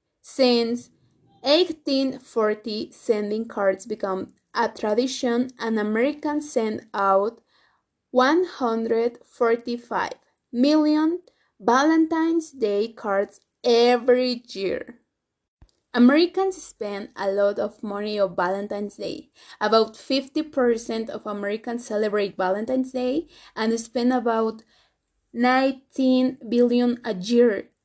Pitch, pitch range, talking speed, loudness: 240 Hz, 215-265 Hz, 90 wpm, -23 LUFS